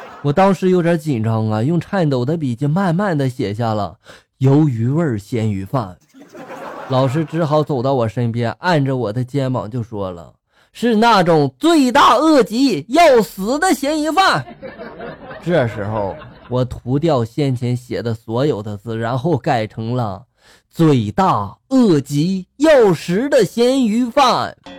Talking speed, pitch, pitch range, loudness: 210 characters per minute, 145 Hz, 115-190 Hz, -16 LUFS